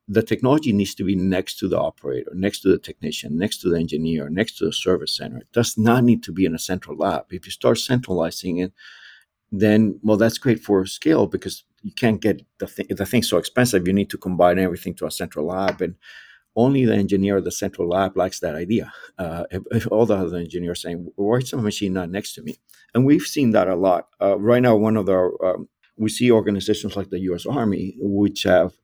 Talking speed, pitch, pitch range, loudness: 235 wpm, 100 Hz, 90-110 Hz, -21 LUFS